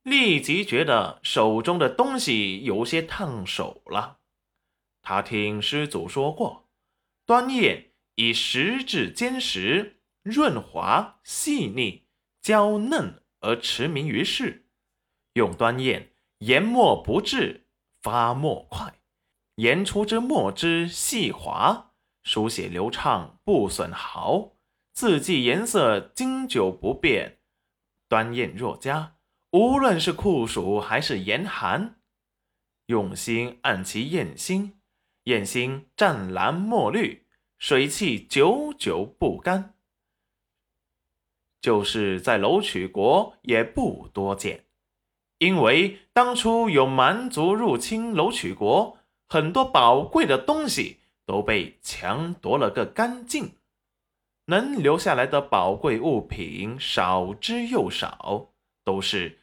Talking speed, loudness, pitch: 155 characters per minute, -24 LUFS, 170 Hz